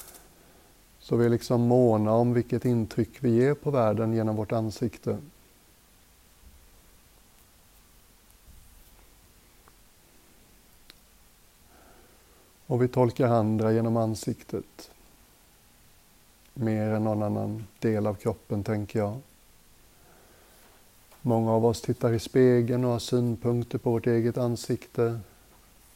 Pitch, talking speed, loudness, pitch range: 115 Hz, 100 wpm, -26 LUFS, 105-120 Hz